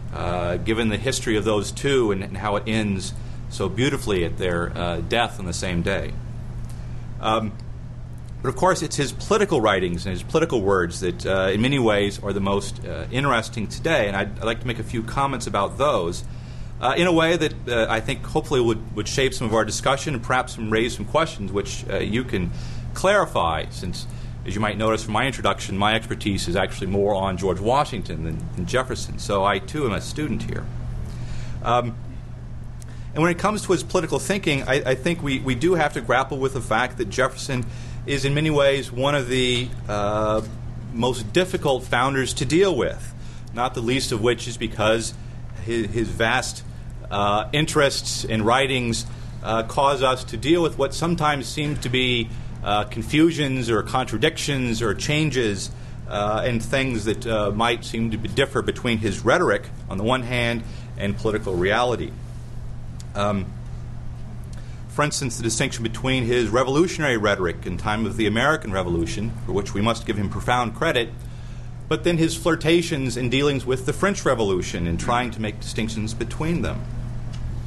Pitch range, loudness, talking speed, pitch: 110-130 Hz, -23 LUFS, 185 wpm, 120 Hz